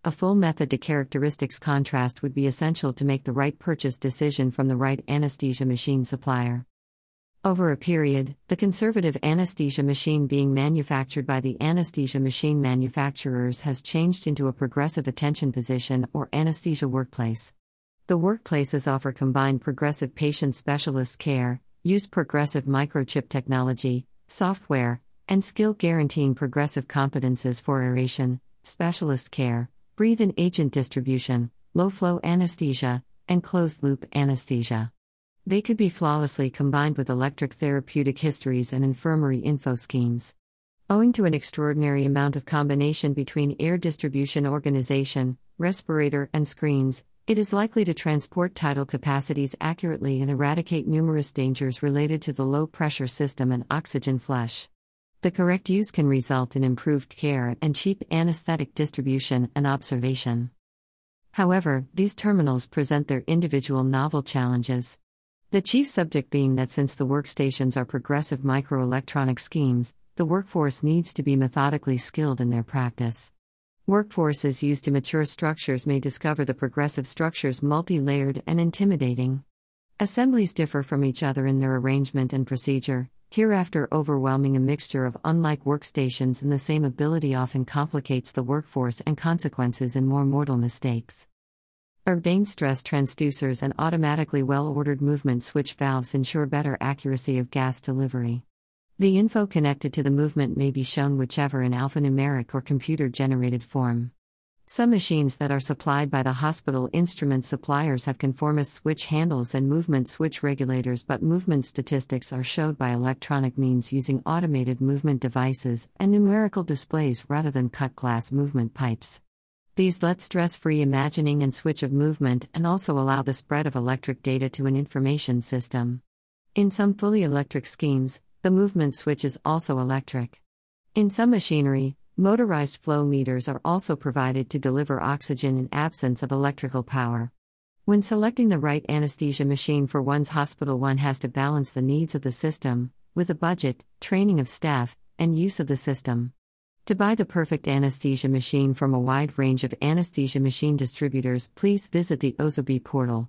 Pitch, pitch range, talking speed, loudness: 140 Hz, 130-155 Hz, 150 wpm, -25 LUFS